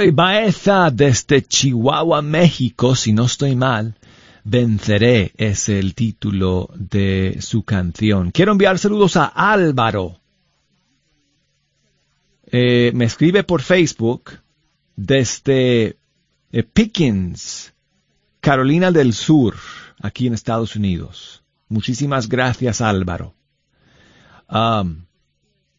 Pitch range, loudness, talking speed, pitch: 105-150 Hz, -16 LUFS, 90 wpm, 120 Hz